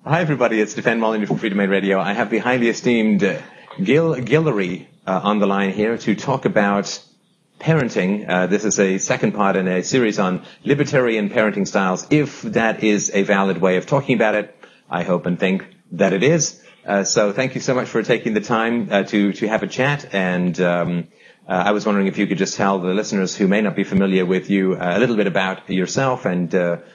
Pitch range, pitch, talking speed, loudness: 95-115 Hz, 100 Hz, 220 wpm, -19 LUFS